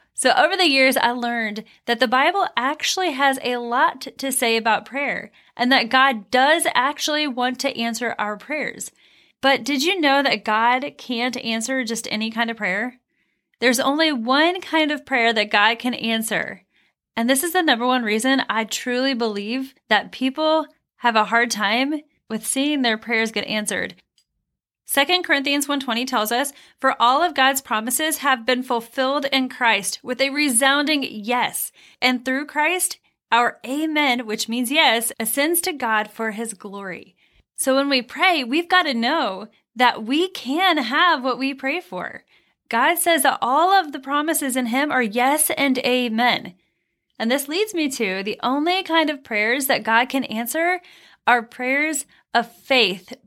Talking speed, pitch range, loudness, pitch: 170 wpm, 235-290 Hz, -20 LUFS, 260 Hz